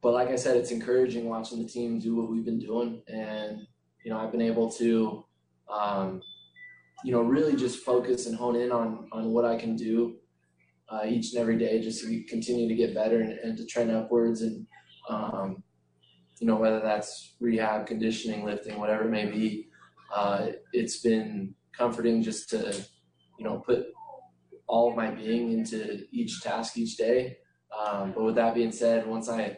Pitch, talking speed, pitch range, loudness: 115 Hz, 185 wpm, 105-120 Hz, -29 LUFS